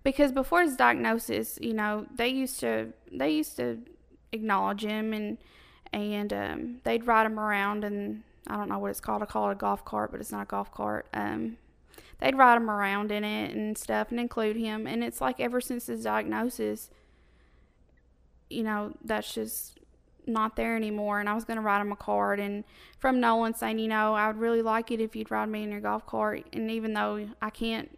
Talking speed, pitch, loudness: 215 wpm, 200 Hz, -29 LUFS